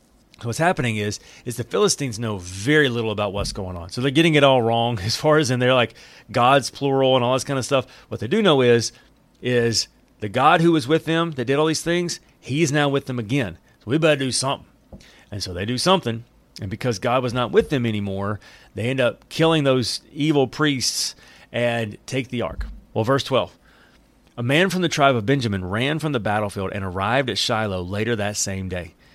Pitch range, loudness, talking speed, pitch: 110-140 Hz, -21 LUFS, 220 wpm, 125 Hz